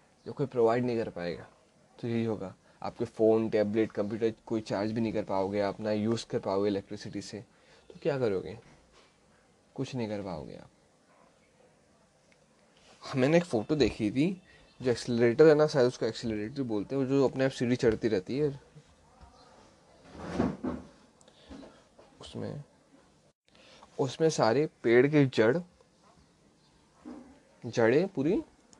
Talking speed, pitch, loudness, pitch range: 125 wpm, 115 Hz, -29 LUFS, 105-135 Hz